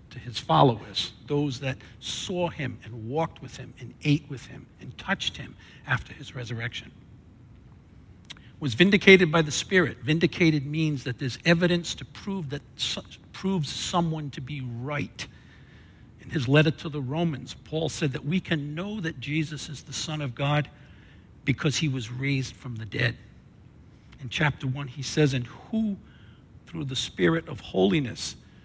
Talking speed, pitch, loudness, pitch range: 160 wpm, 140 Hz, -27 LUFS, 125-160 Hz